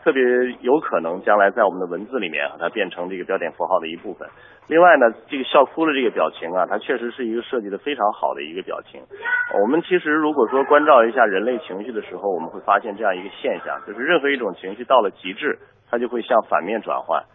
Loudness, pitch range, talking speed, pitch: -20 LUFS, 125-180 Hz, 375 characters per minute, 145 Hz